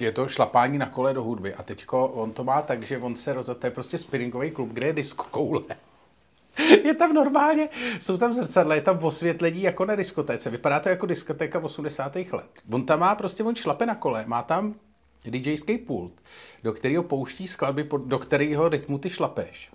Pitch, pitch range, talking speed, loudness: 150 Hz, 130-190 Hz, 200 wpm, -25 LUFS